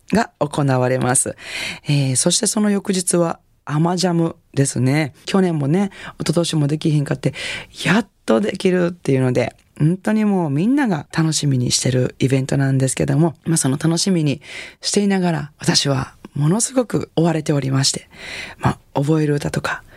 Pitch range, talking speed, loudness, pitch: 140-175 Hz, 350 characters per minute, -19 LUFS, 155 Hz